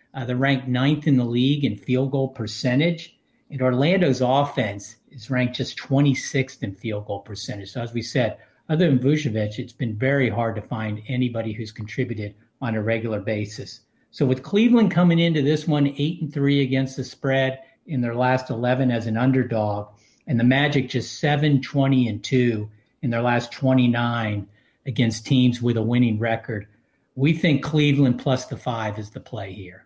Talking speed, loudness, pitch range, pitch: 175 wpm, -22 LUFS, 115-140 Hz, 125 Hz